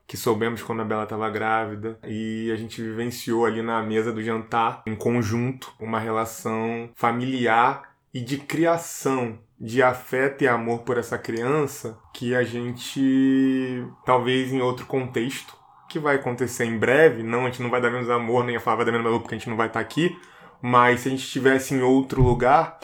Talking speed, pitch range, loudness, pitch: 190 wpm, 115-130 Hz, -23 LUFS, 120 Hz